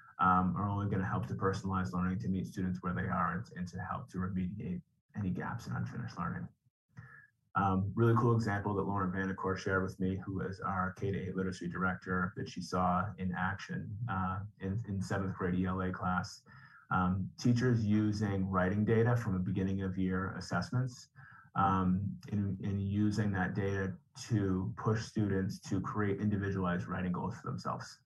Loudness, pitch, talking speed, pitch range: -35 LUFS, 95 Hz, 175 wpm, 95-105 Hz